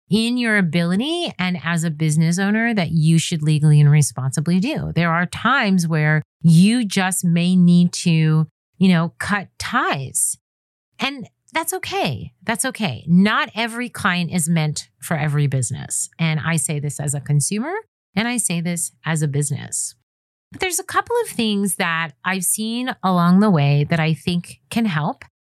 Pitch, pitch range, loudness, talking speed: 175 Hz, 155-210 Hz, -19 LUFS, 170 wpm